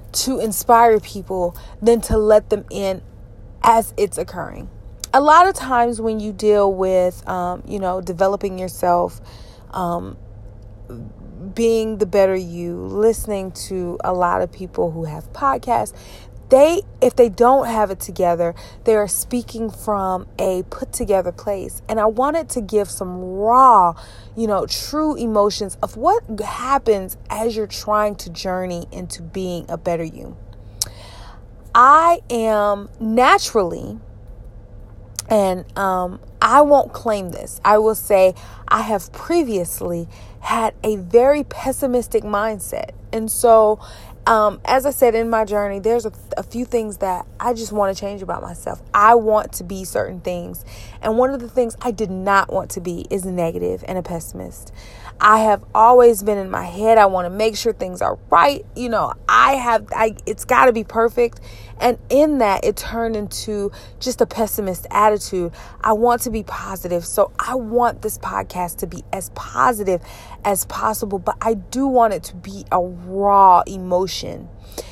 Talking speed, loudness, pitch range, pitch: 160 wpm, -18 LUFS, 180-230 Hz, 205 Hz